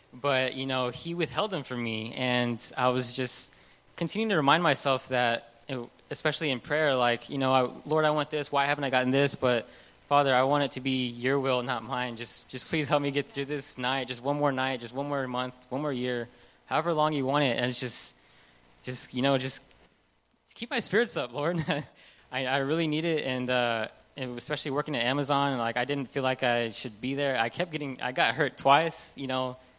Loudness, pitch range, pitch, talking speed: -29 LUFS, 125-145 Hz, 130 Hz, 220 wpm